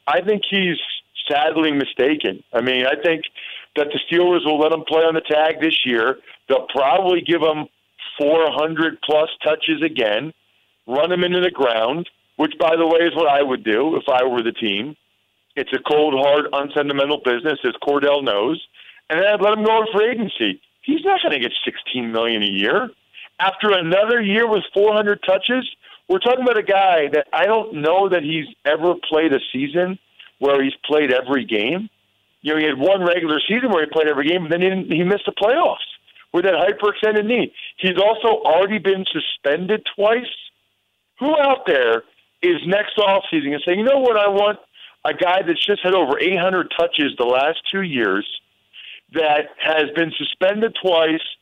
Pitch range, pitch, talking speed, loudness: 150-205 Hz, 170 Hz, 190 wpm, -18 LUFS